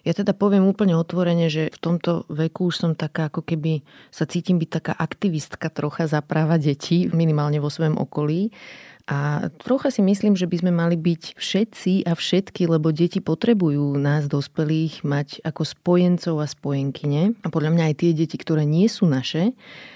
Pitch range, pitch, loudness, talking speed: 155-180 Hz, 165 Hz, -22 LUFS, 175 wpm